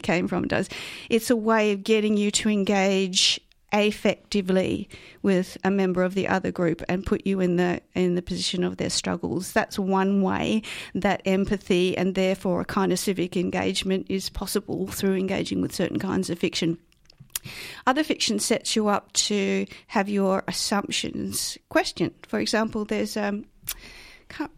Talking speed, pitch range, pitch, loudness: 160 wpm, 185-210 Hz, 195 Hz, -25 LUFS